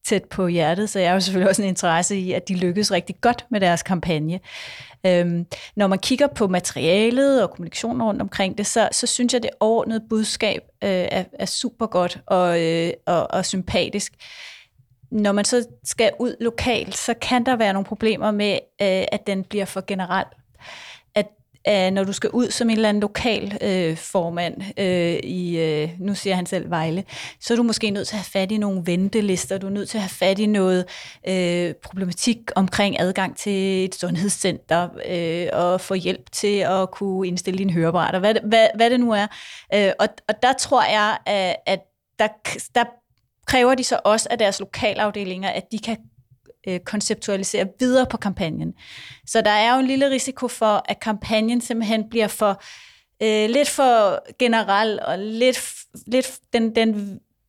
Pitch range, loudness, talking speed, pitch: 185-225 Hz, -21 LUFS, 185 wpm, 200 Hz